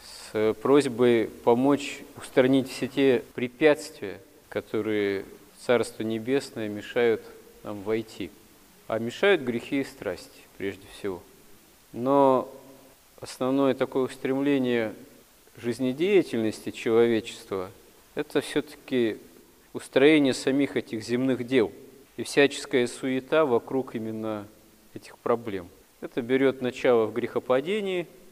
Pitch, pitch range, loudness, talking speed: 130 Hz, 115-140 Hz, -26 LUFS, 95 wpm